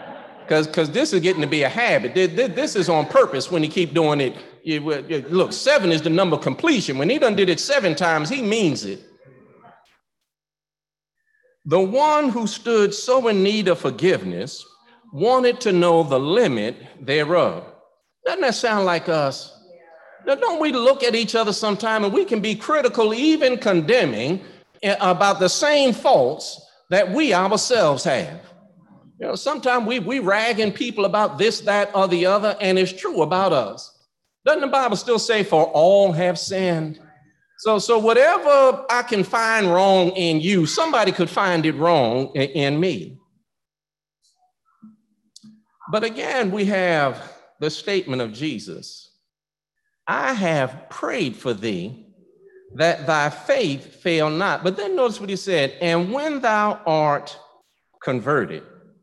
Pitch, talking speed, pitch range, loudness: 200 Hz, 150 wpm, 170-245 Hz, -19 LUFS